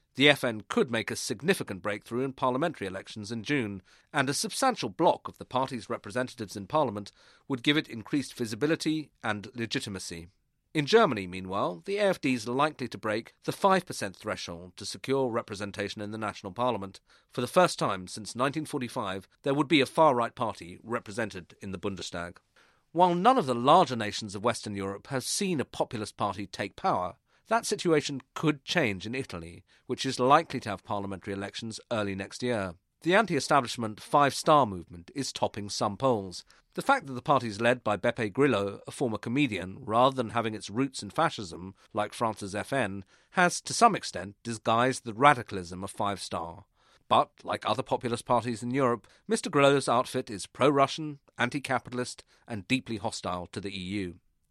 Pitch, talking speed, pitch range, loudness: 120 Hz, 175 wpm, 100-140 Hz, -29 LUFS